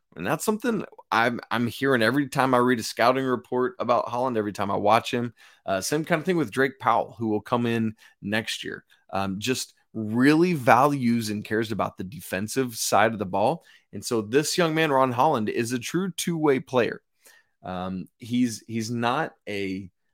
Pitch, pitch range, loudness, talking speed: 125 Hz, 110-140 Hz, -25 LUFS, 190 wpm